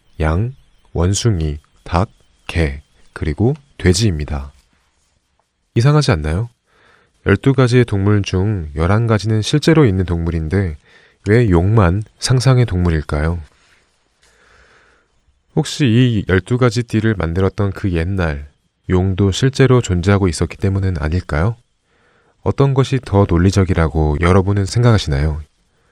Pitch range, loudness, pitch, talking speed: 80-115 Hz, -16 LUFS, 95 Hz, 240 characters per minute